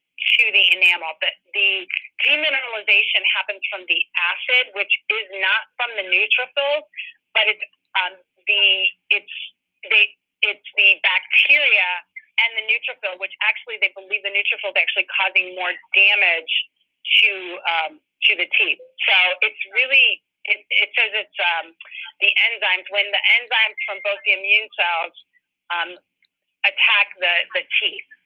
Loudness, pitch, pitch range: -17 LUFS, 200 Hz, 180-225 Hz